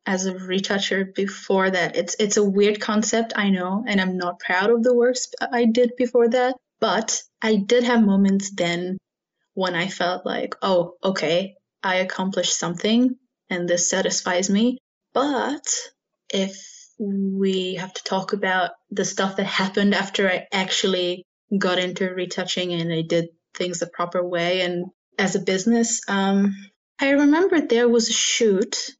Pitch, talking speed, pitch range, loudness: 195 Hz, 160 wpm, 185-235 Hz, -22 LUFS